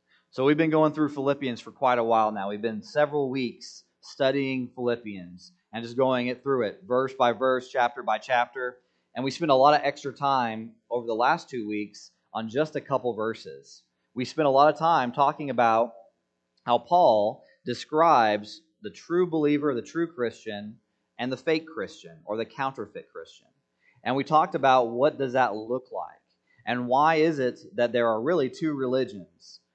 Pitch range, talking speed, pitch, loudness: 115-145 Hz, 185 wpm, 125 Hz, -25 LUFS